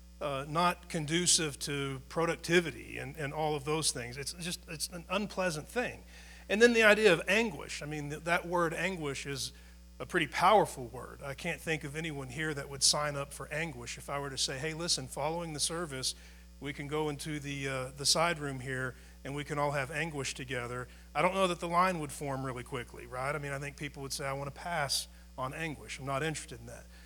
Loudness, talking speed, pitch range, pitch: -32 LUFS, 225 wpm, 135-165 Hz, 145 Hz